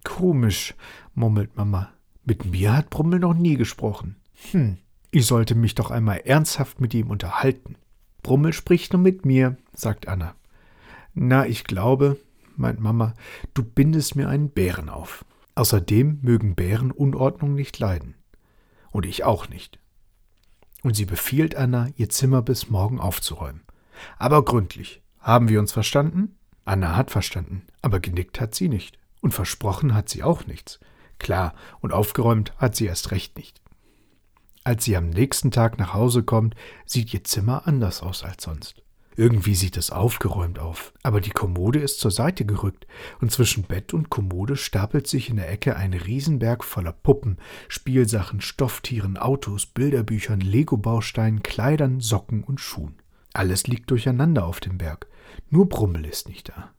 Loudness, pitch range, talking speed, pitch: -23 LUFS, 100-130 Hz, 155 wpm, 110 Hz